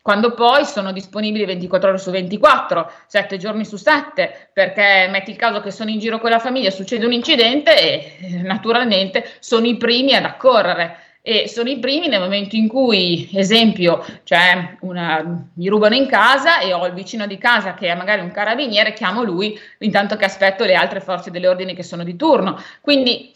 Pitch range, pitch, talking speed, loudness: 185-235 Hz, 205 Hz, 190 wpm, -16 LUFS